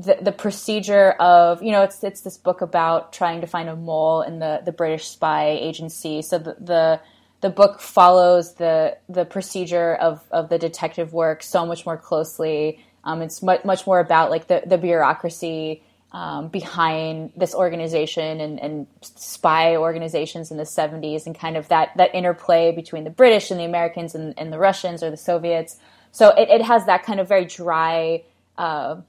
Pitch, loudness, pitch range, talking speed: 165 Hz, -19 LUFS, 160-180 Hz, 185 wpm